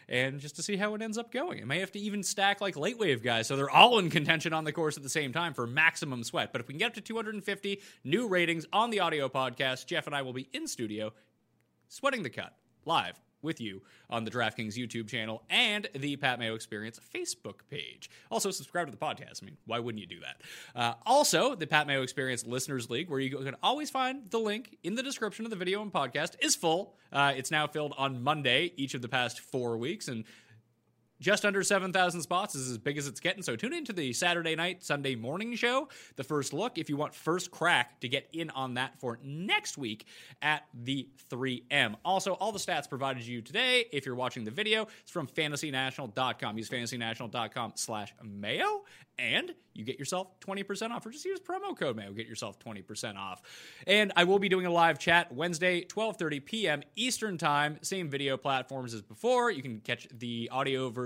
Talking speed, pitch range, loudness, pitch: 220 wpm, 125-195 Hz, -31 LUFS, 150 Hz